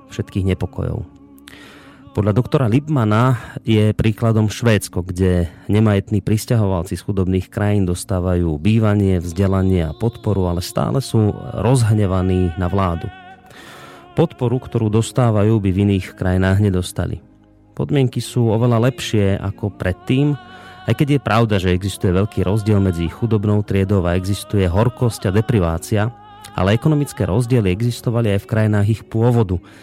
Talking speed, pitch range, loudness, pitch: 130 wpm, 95-115 Hz, -18 LUFS, 105 Hz